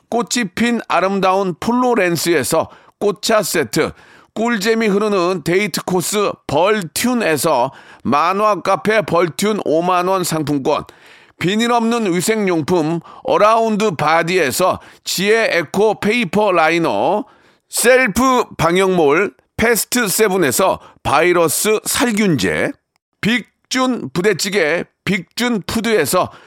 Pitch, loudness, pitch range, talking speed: 205 Hz, -16 LUFS, 175-225 Hz, 225 characters per minute